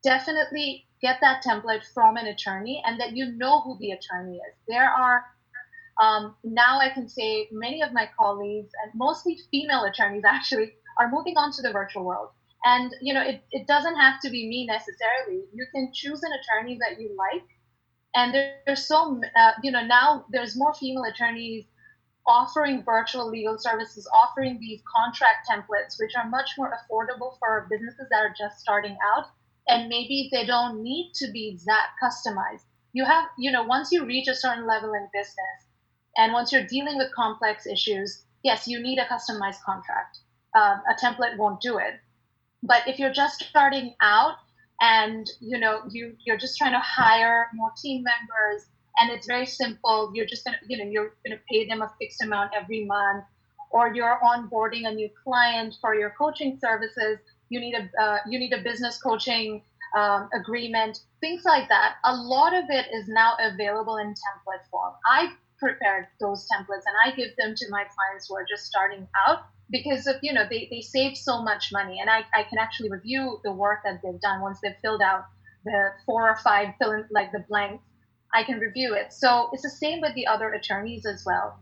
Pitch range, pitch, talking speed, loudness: 215-260 Hz, 235 Hz, 195 wpm, -24 LUFS